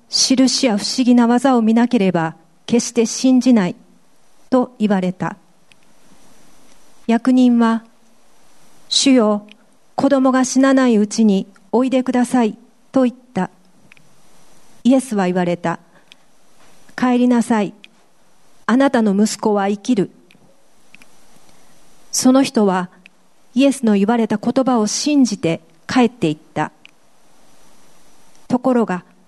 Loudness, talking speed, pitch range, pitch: -16 LUFS, 210 characters per minute, 200-255 Hz, 230 Hz